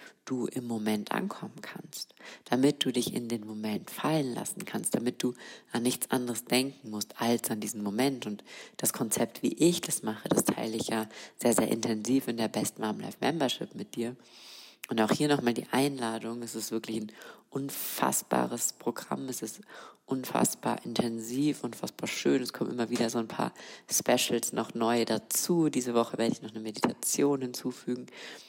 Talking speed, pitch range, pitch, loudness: 175 wpm, 110-125 Hz, 120 Hz, -31 LUFS